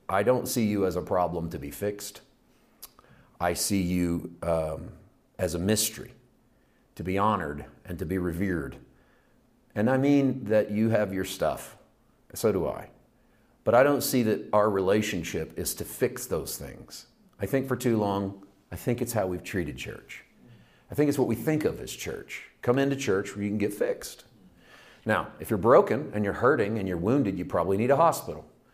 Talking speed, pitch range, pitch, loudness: 190 wpm, 90-120 Hz, 100 Hz, -27 LUFS